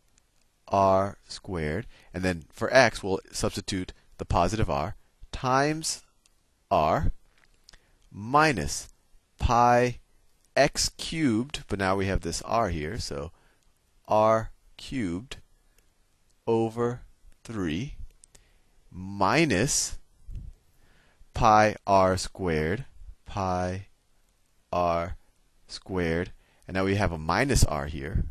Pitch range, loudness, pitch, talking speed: 85-110 Hz, -27 LUFS, 95 Hz, 95 wpm